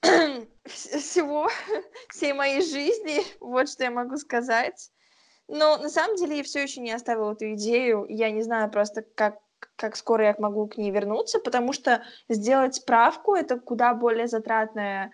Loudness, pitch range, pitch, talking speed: -25 LUFS, 220-285 Hz, 240 Hz, 160 wpm